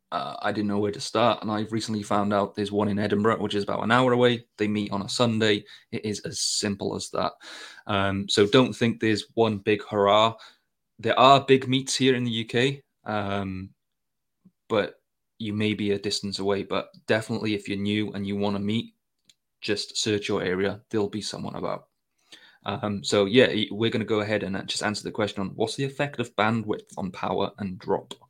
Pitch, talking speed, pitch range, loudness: 105 Hz, 210 wpm, 100-115 Hz, -25 LUFS